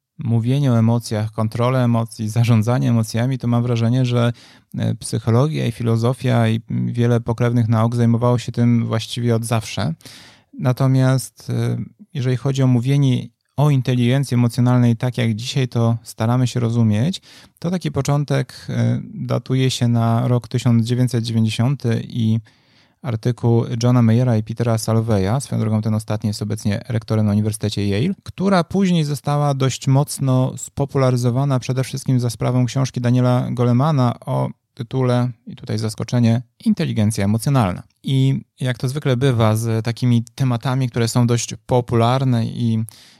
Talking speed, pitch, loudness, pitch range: 135 wpm, 120 Hz, -19 LUFS, 115-130 Hz